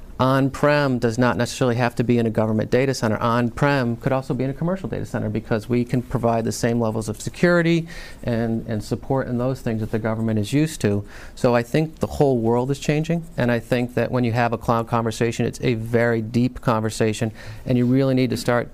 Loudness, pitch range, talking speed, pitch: -22 LUFS, 115-130 Hz, 235 wpm, 120 Hz